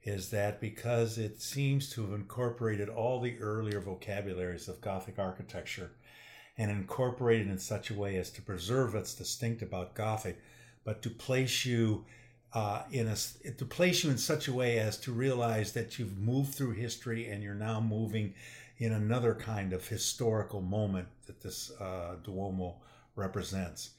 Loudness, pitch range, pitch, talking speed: -35 LUFS, 100-120 Hz, 110 Hz, 165 wpm